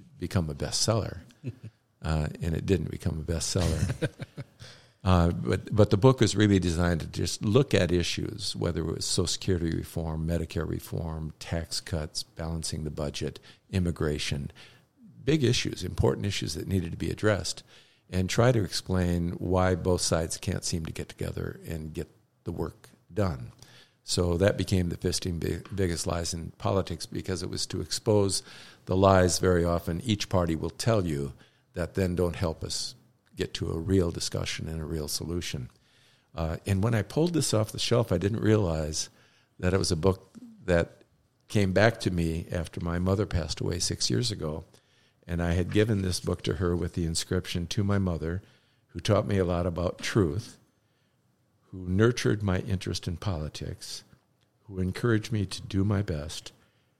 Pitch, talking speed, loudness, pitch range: 95 Hz, 175 wpm, -29 LUFS, 85-110 Hz